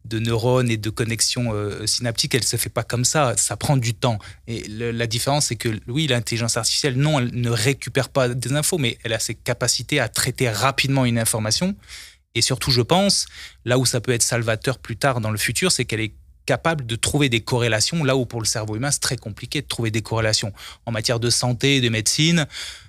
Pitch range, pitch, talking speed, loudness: 115-135 Hz, 120 Hz, 225 wpm, -21 LUFS